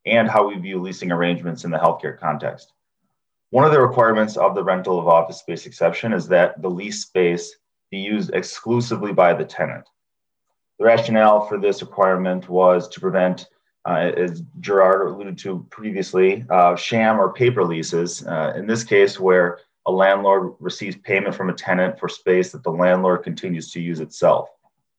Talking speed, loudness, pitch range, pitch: 175 wpm, -19 LUFS, 90-110 Hz, 95 Hz